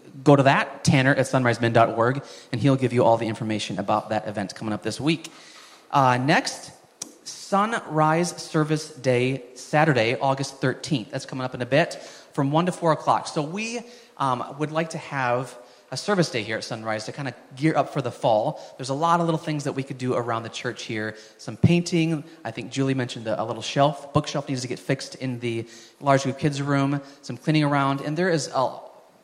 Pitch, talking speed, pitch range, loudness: 135 Hz, 205 wpm, 120-155 Hz, -24 LUFS